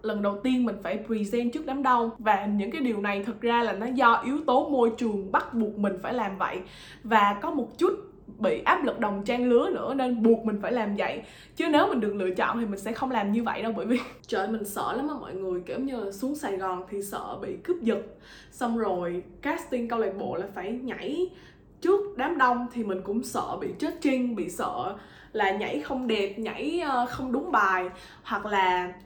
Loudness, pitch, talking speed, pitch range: -27 LUFS, 230 Hz, 230 wpm, 205-260 Hz